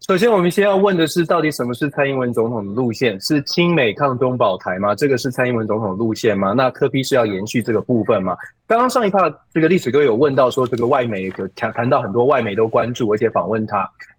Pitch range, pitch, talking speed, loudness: 115-170 Hz, 135 Hz, 370 characters per minute, -17 LUFS